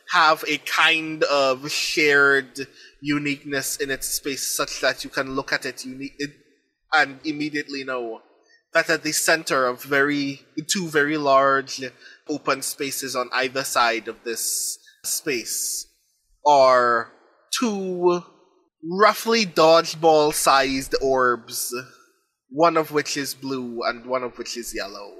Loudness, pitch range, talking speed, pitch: -21 LUFS, 130-160 Hz, 130 wpm, 145 Hz